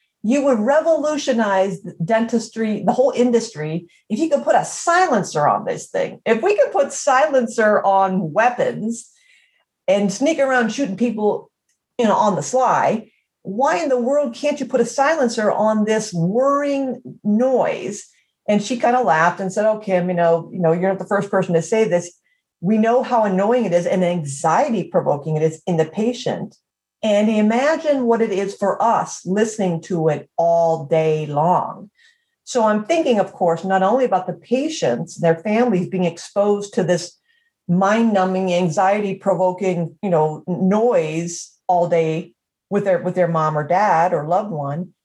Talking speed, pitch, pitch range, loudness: 175 wpm, 205 Hz, 180-250 Hz, -19 LUFS